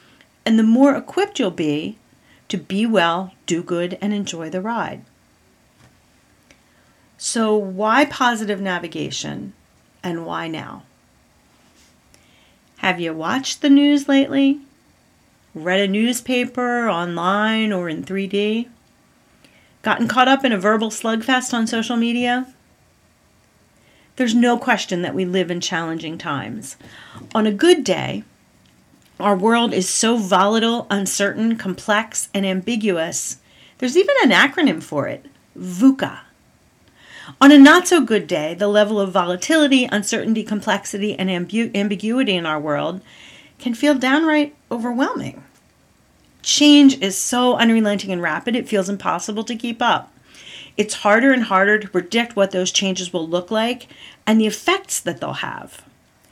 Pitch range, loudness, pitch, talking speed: 190-245 Hz, -18 LUFS, 215 Hz, 135 wpm